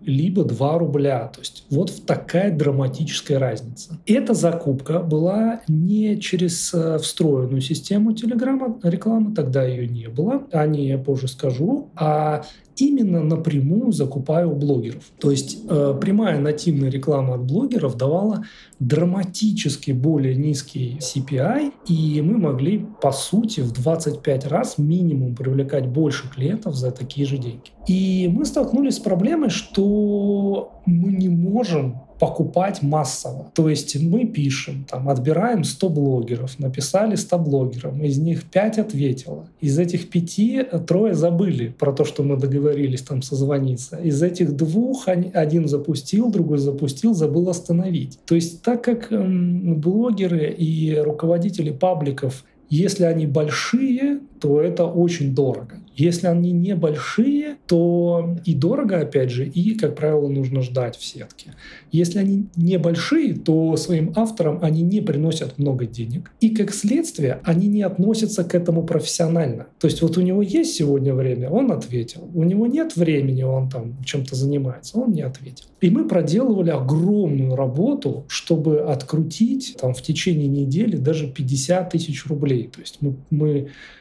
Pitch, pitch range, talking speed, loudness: 160 Hz, 140-190 Hz, 140 wpm, -20 LUFS